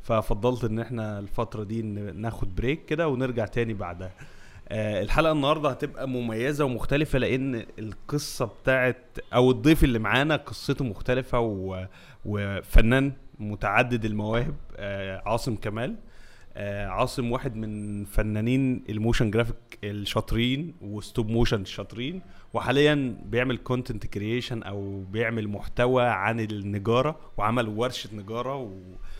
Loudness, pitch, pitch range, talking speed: -27 LUFS, 115 Hz, 105-125 Hz, 110 wpm